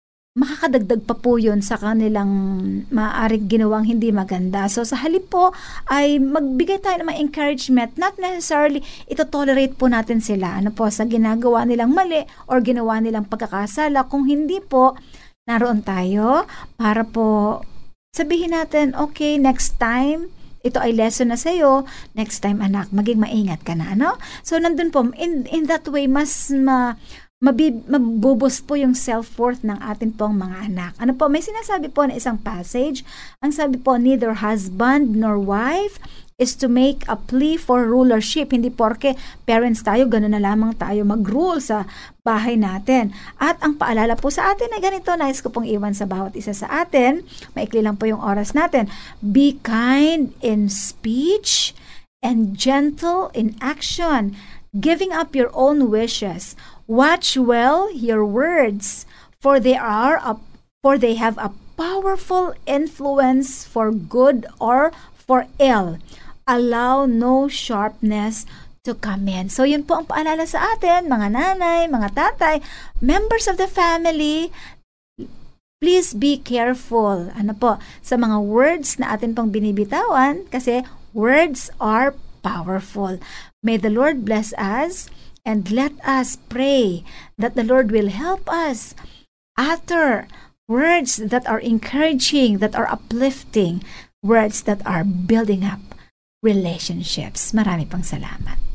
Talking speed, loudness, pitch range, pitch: 145 wpm, -19 LUFS, 215-290 Hz, 250 Hz